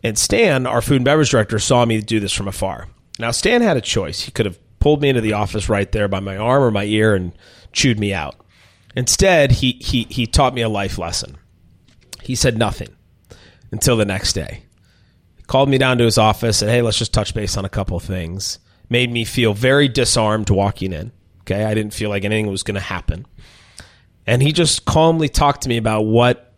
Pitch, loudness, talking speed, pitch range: 110 Hz, -17 LUFS, 220 wpm, 100-120 Hz